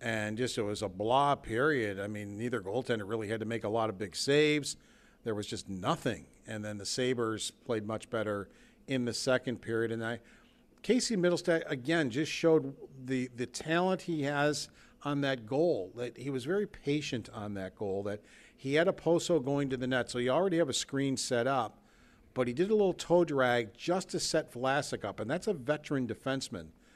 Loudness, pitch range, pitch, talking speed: -32 LUFS, 115-155 Hz, 130 Hz, 205 wpm